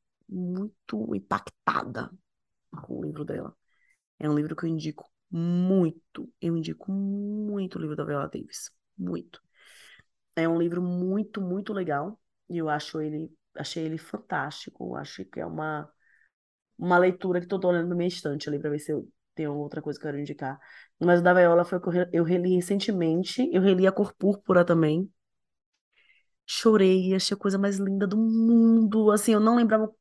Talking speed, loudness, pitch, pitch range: 180 wpm, -26 LUFS, 180 Hz, 155-200 Hz